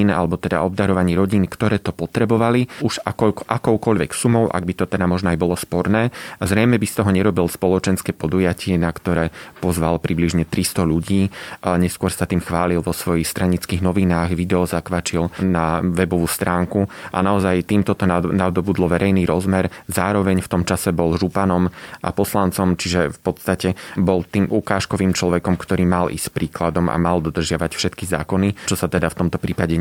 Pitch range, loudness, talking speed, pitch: 85-95 Hz, -19 LUFS, 170 wpm, 90 Hz